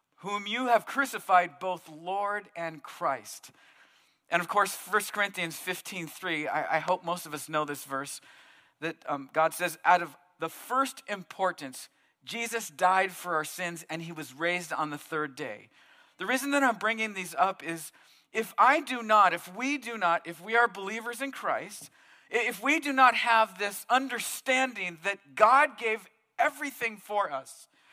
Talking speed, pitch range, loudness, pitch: 170 wpm, 170-235 Hz, -29 LUFS, 195 Hz